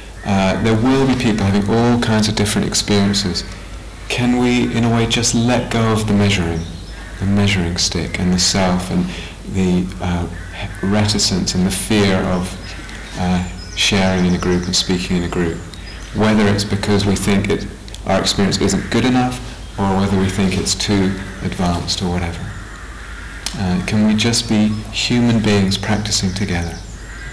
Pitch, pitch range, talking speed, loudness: 95 Hz, 90-105 Hz, 165 wpm, -17 LUFS